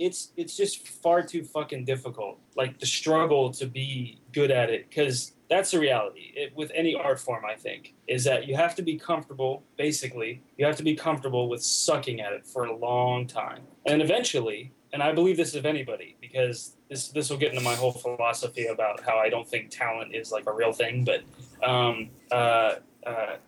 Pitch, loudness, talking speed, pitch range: 135 Hz, -27 LUFS, 200 wpm, 125-155 Hz